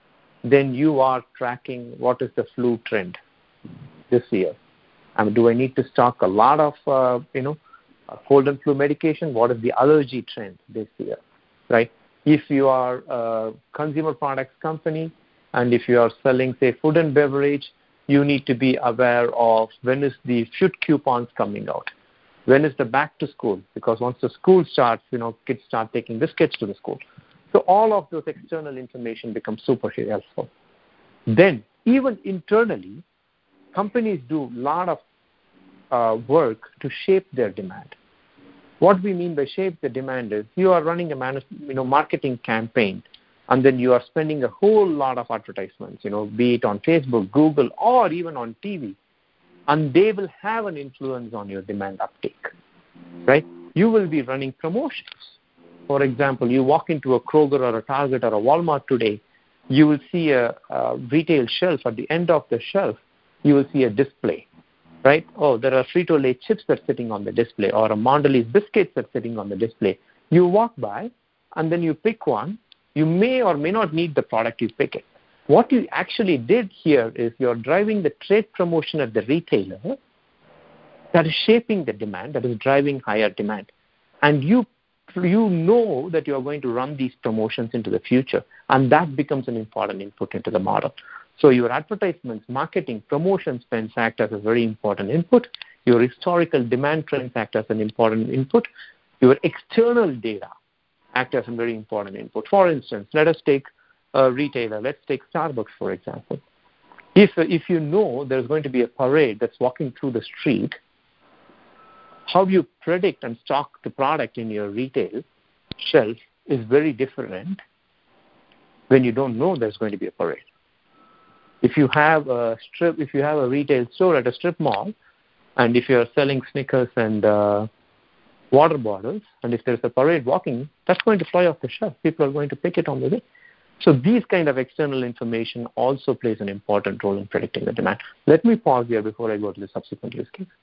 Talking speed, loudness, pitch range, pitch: 190 wpm, -21 LUFS, 120-165 Hz, 135 Hz